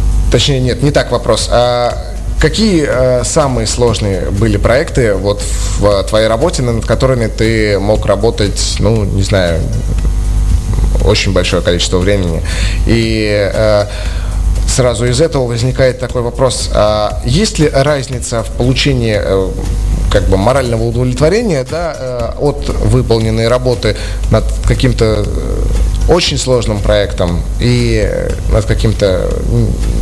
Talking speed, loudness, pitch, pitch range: 120 wpm, -12 LUFS, 110 Hz, 100-125 Hz